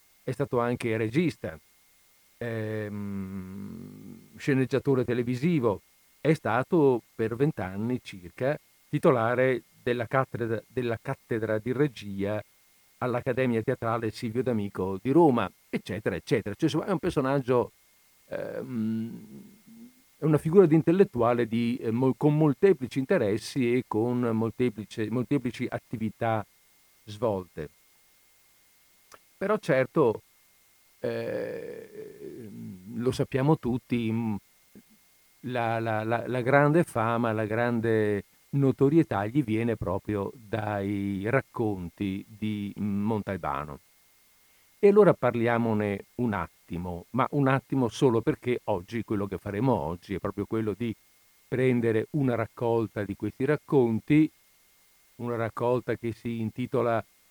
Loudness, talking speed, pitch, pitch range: -28 LUFS, 105 wpm, 120 Hz, 105-135 Hz